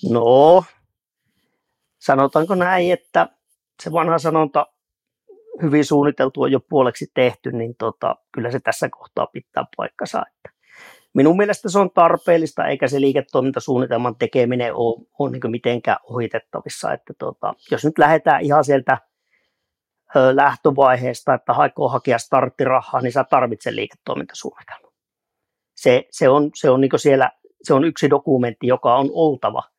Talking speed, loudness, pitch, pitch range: 135 wpm, -18 LUFS, 145 Hz, 125-160 Hz